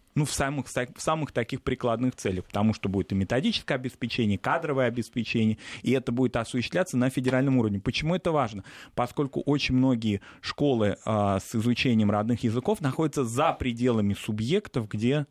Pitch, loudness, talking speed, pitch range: 125 Hz, -27 LUFS, 160 wpm, 110-135 Hz